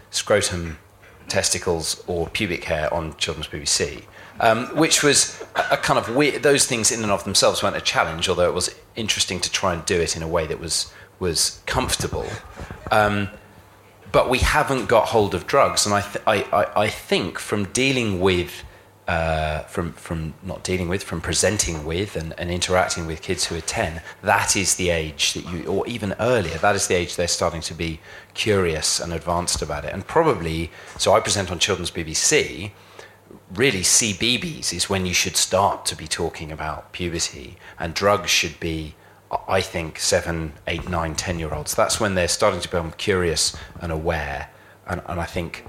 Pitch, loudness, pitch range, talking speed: 90 Hz, -21 LUFS, 80-100 Hz, 190 wpm